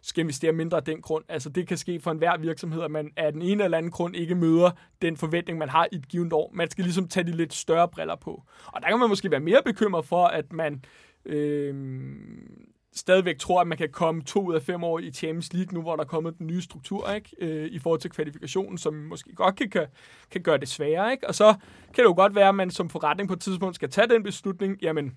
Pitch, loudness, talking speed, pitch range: 170 Hz, -25 LUFS, 255 wpm, 160-190 Hz